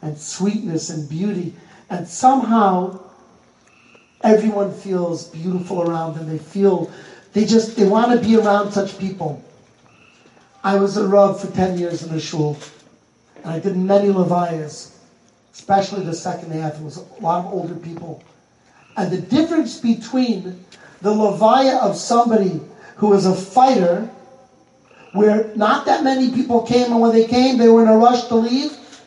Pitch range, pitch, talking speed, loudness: 175-225 Hz, 195 Hz, 160 wpm, -17 LUFS